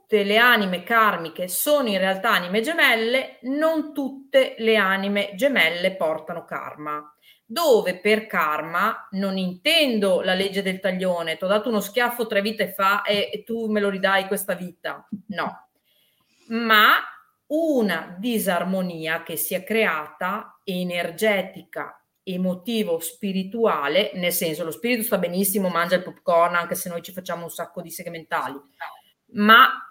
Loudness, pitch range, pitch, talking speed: -22 LUFS, 175-225 Hz, 195 Hz, 140 wpm